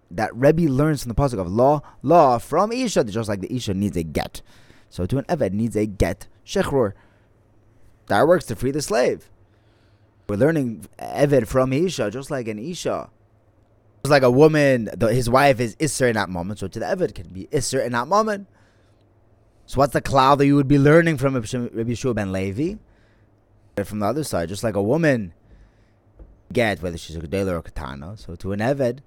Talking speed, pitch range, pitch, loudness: 200 wpm, 100-135 Hz, 110 Hz, -21 LUFS